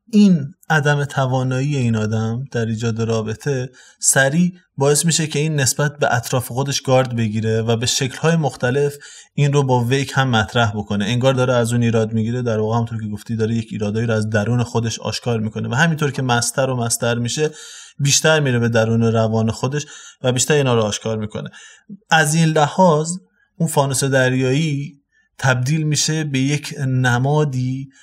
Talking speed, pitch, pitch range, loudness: 170 wpm, 130 Hz, 115-145 Hz, -18 LUFS